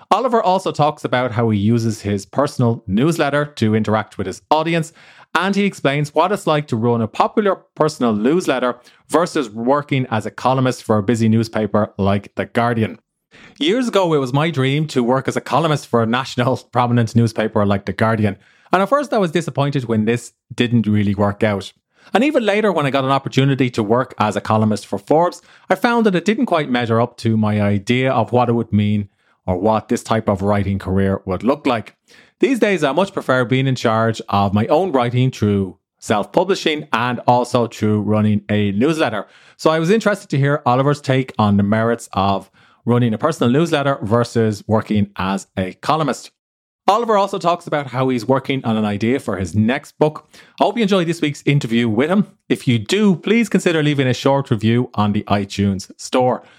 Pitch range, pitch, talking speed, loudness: 110-150 Hz, 125 Hz, 200 wpm, -18 LUFS